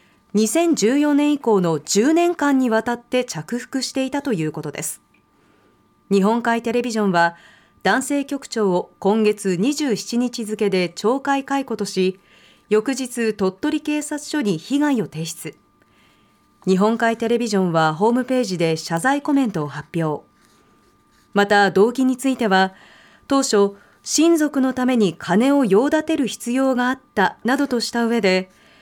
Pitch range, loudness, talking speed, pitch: 190-265 Hz, -20 LUFS, 260 characters per minute, 230 Hz